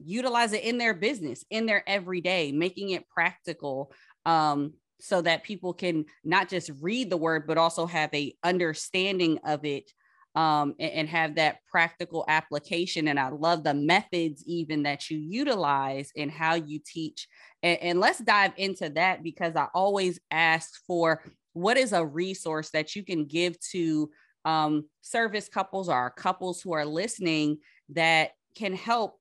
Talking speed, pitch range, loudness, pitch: 160 wpm, 155-185 Hz, -27 LUFS, 165 Hz